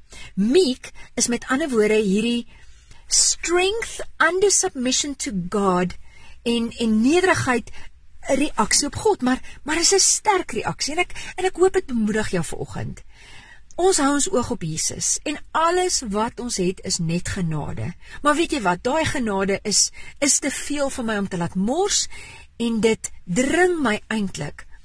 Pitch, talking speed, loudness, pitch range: 245 Hz, 160 wpm, -21 LUFS, 210-320 Hz